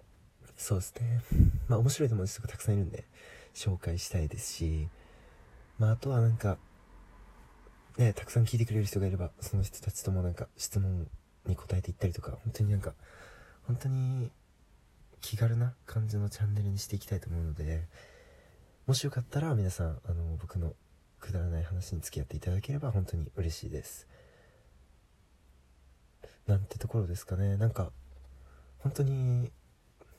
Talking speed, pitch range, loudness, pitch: 330 characters per minute, 80-110 Hz, -33 LUFS, 95 Hz